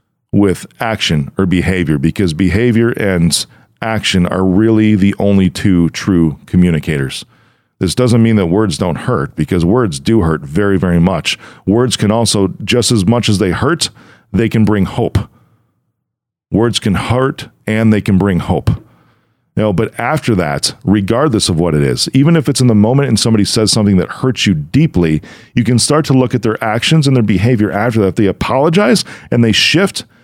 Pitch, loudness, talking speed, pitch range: 105 Hz, -13 LUFS, 180 wpm, 95-120 Hz